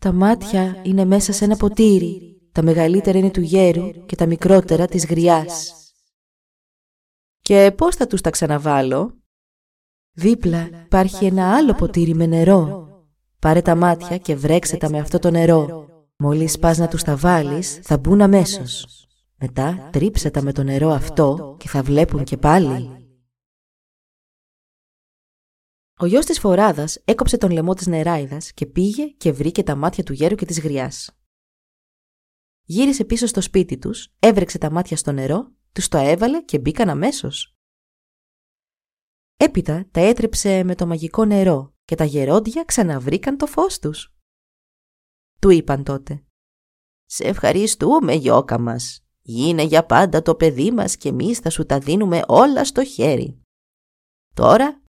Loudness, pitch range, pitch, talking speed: -17 LUFS, 150-195 Hz, 170 Hz, 145 wpm